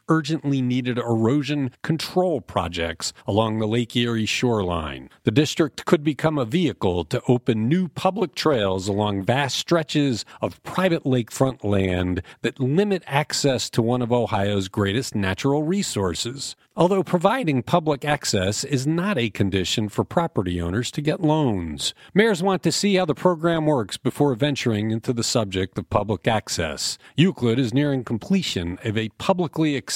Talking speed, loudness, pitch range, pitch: 150 wpm, -22 LUFS, 105-155 Hz, 130 Hz